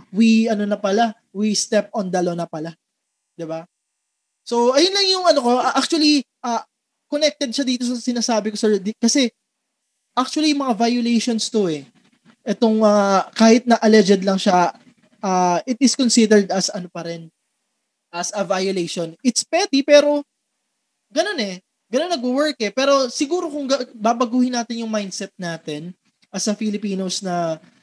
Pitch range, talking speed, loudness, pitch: 200-255 Hz, 160 wpm, -19 LUFS, 225 Hz